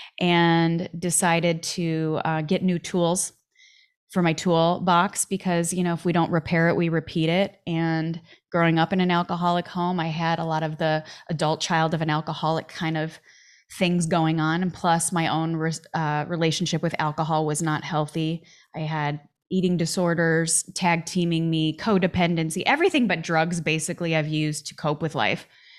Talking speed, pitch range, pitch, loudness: 170 wpm, 160-175 Hz, 165 Hz, -24 LUFS